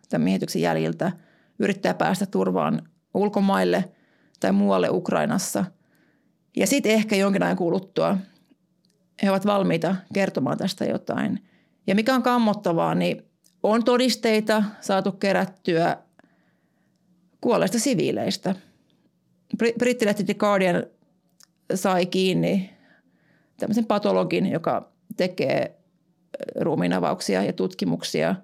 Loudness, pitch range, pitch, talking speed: -23 LUFS, 180-210 Hz, 195 Hz, 95 wpm